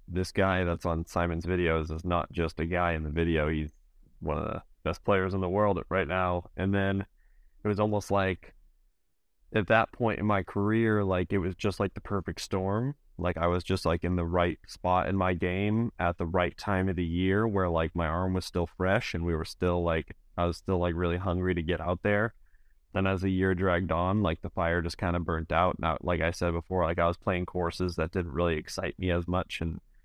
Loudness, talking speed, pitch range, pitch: -29 LUFS, 240 wpm, 85-95 Hz, 90 Hz